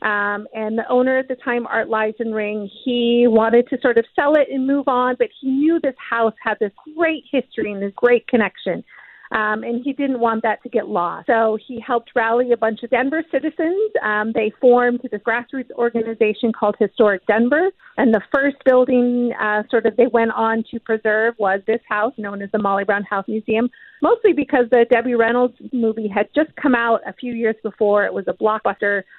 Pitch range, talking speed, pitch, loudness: 215-255 Hz, 210 wpm, 235 Hz, -19 LUFS